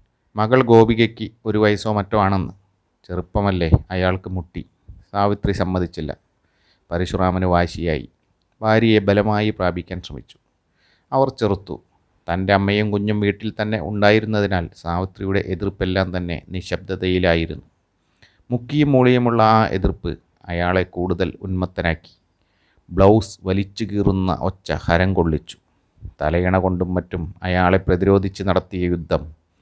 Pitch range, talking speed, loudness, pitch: 90-105 Hz, 100 wpm, -20 LUFS, 95 Hz